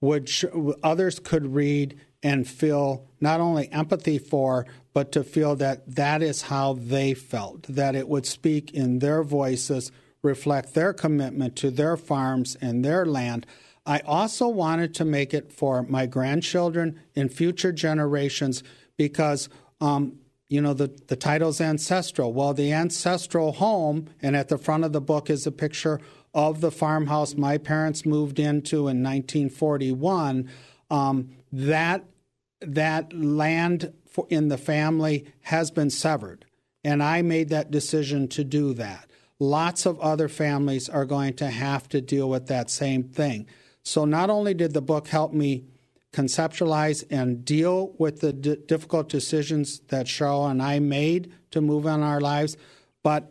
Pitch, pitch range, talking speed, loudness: 145 Hz, 135-155 Hz, 155 wpm, -25 LUFS